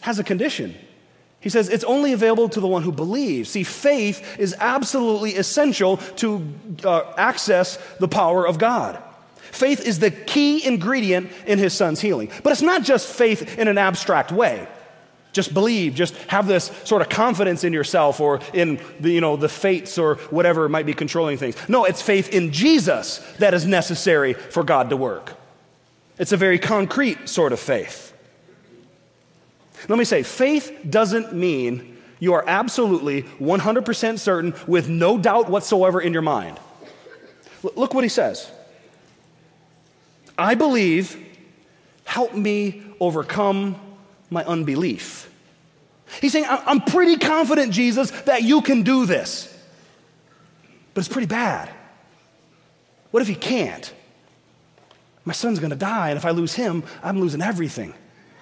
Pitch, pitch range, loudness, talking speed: 195 Hz, 170-235 Hz, -20 LUFS, 150 wpm